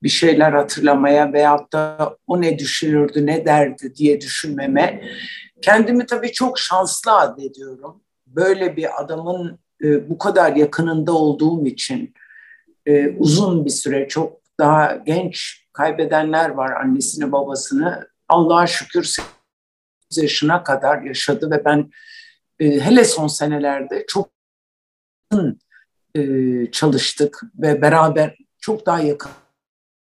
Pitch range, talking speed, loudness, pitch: 145-185 Hz, 105 wpm, -17 LUFS, 155 Hz